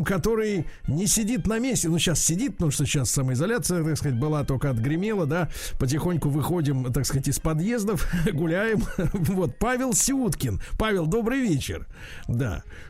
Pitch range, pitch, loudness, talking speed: 140-210 Hz, 165 Hz, -25 LUFS, 150 wpm